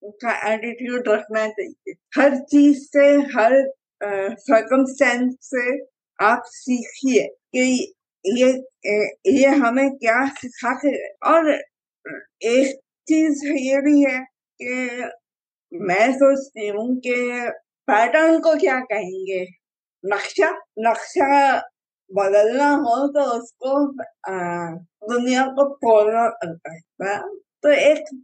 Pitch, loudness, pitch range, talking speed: 255 Hz, -19 LUFS, 220-285 Hz, 75 wpm